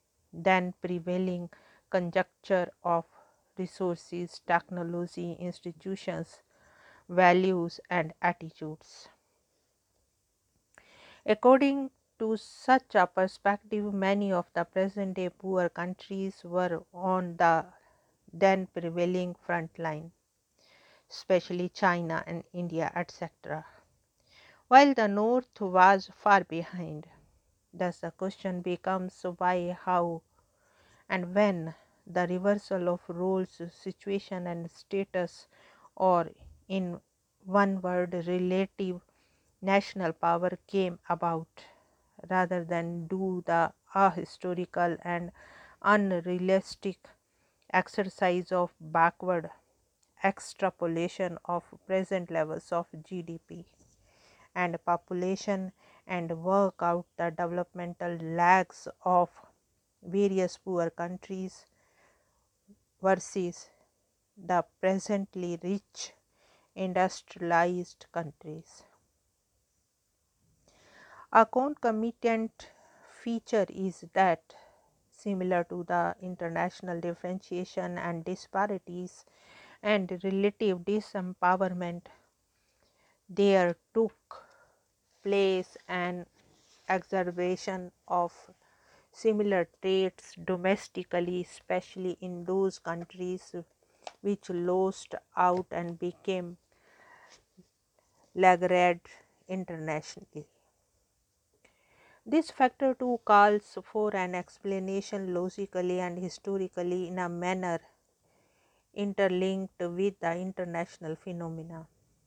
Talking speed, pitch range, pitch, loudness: 80 wpm, 175-195 Hz, 180 Hz, -30 LUFS